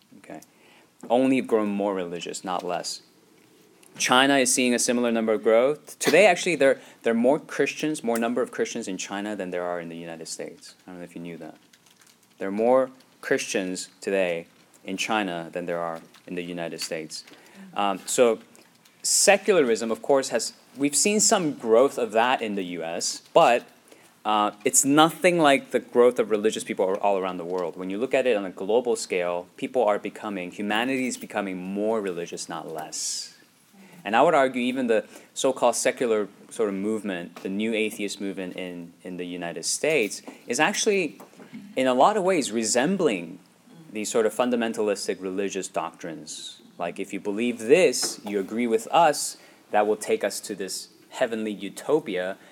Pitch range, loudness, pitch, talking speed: 90-125 Hz, -24 LUFS, 105 Hz, 180 wpm